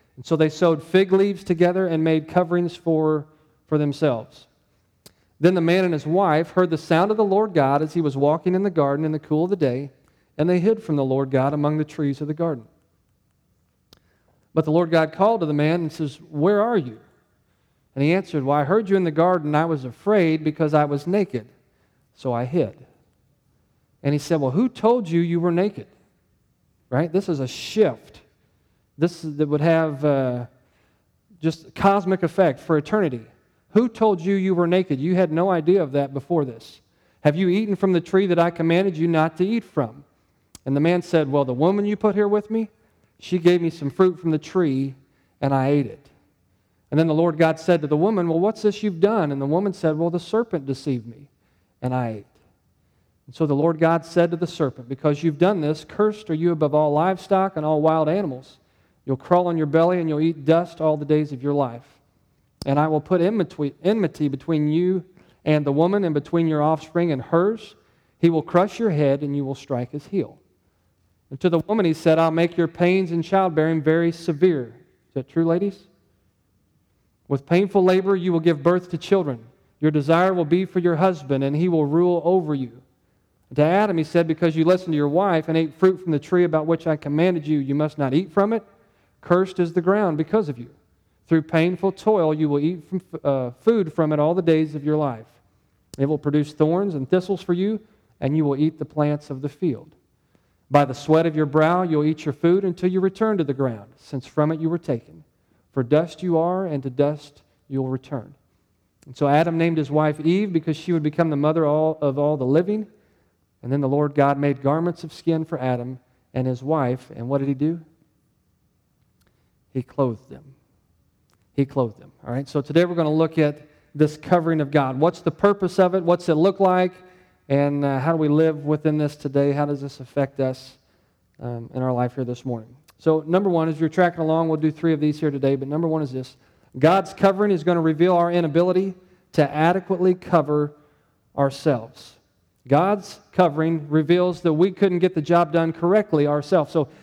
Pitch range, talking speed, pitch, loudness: 140-175 Hz, 215 wpm, 155 Hz, -21 LUFS